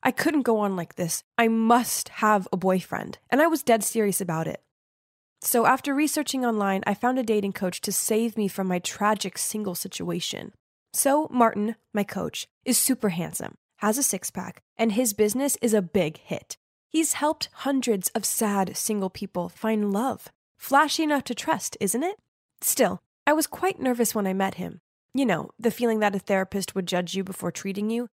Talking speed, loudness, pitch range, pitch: 190 wpm, -25 LUFS, 195-245 Hz, 215 Hz